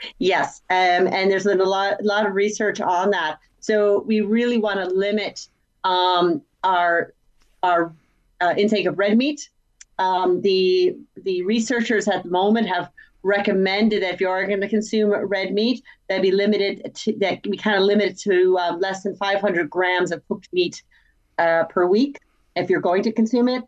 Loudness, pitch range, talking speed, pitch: -20 LUFS, 185-215 Hz, 190 wpm, 200 Hz